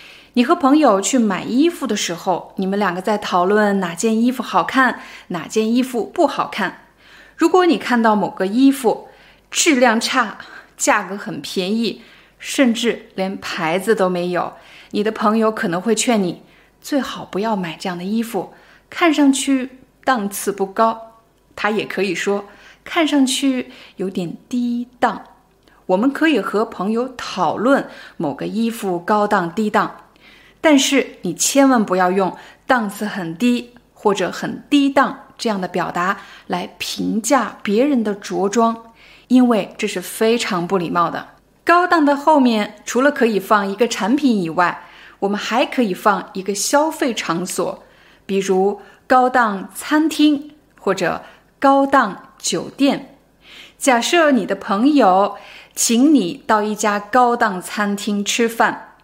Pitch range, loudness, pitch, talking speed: 200-265 Hz, -18 LUFS, 225 Hz, 210 characters per minute